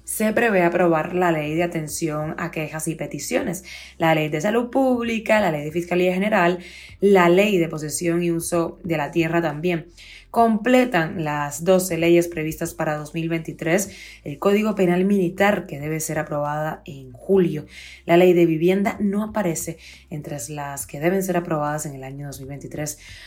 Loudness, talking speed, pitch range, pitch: -21 LUFS, 165 wpm, 155-180 Hz, 170 Hz